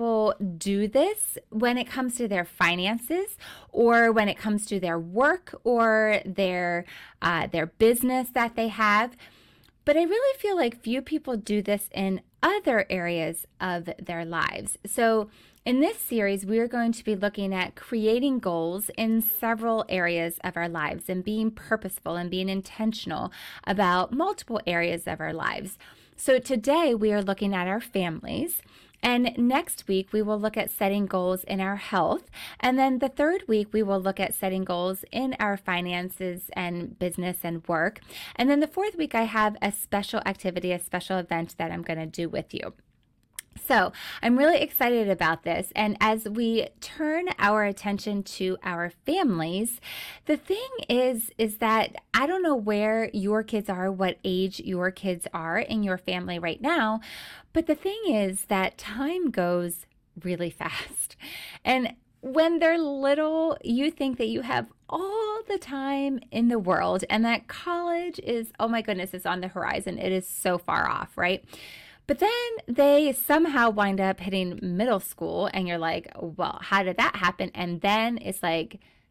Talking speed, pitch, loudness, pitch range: 170 wpm, 215 Hz, -26 LUFS, 185-255 Hz